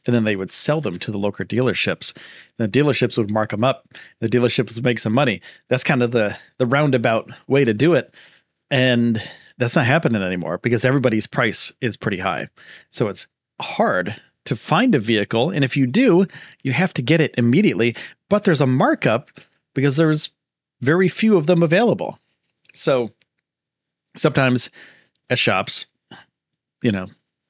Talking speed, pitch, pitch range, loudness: 170 wpm, 130 Hz, 115-150 Hz, -19 LUFS